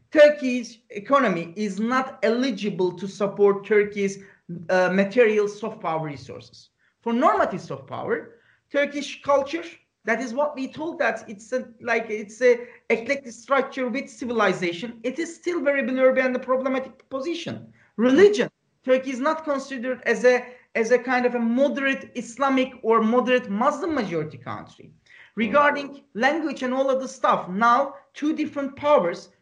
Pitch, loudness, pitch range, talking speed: 250 Hz, -23 LUFS, 215-275 Hz, 150 wpm